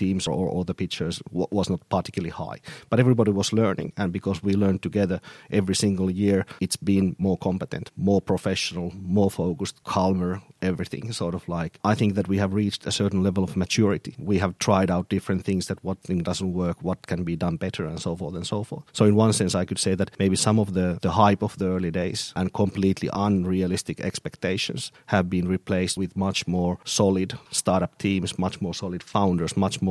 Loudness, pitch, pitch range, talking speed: -25 LUFS, 95 Hz, 90-100 Hz, 210 wpm